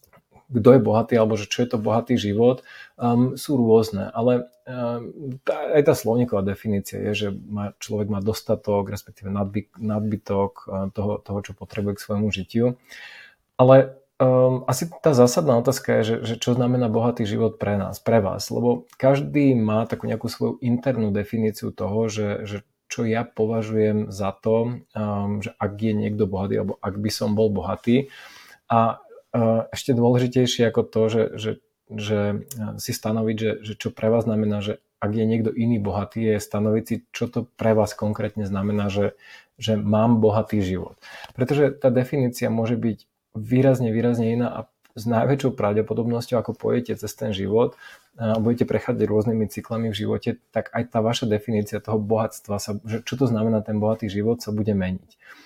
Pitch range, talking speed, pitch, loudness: 105-120 Hz, 170 wpm, 110 Hz, -23 LUFS